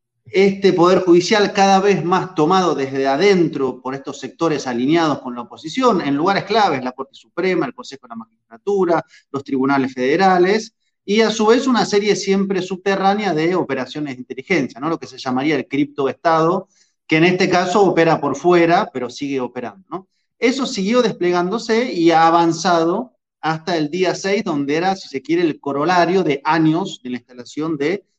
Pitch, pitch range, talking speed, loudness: 170 Hz, 140-195 Hz, 175 wpm, -17 LUFS